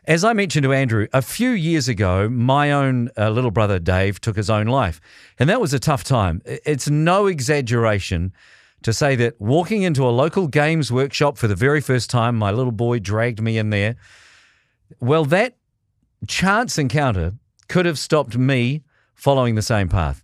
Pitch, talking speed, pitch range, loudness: 130 Hz, 180 wpm, 110-150 Hz, -19 LUFS